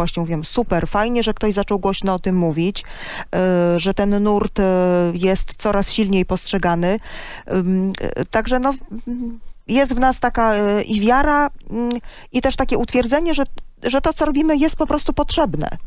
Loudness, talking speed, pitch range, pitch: -19 LUFS, 180 wpm, 185-255 Hz, 215 Hz